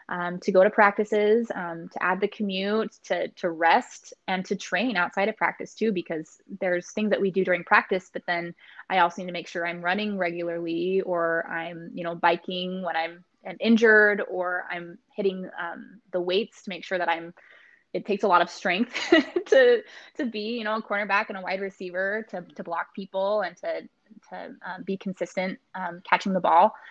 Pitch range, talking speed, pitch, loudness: 175-210 Hz, 200 wpm, 190 Hz, -25 LUFS